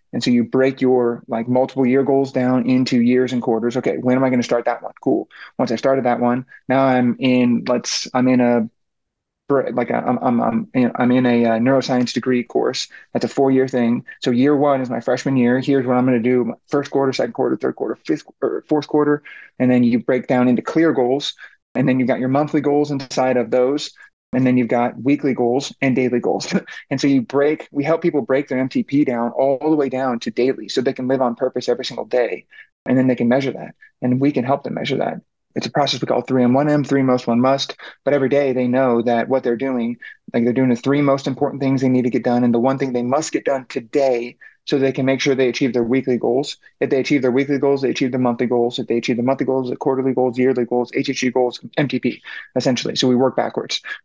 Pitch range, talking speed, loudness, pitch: 125-135 Hz, 245 wpm, -18 LUFS, 130 Hz